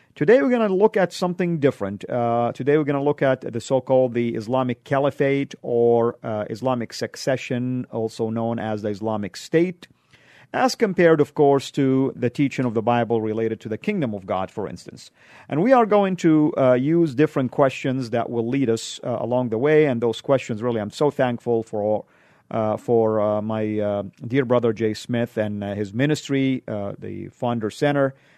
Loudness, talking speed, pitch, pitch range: -22 LUFS, 190 wpm, 125 Hz, 110-140 Hz